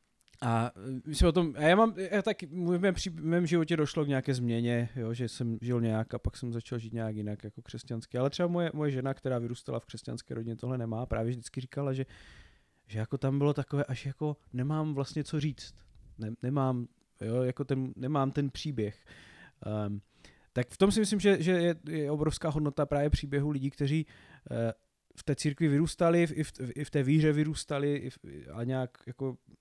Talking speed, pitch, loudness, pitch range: 210 wpm, 135 Hz, -32 LUFS, 115-150 Hz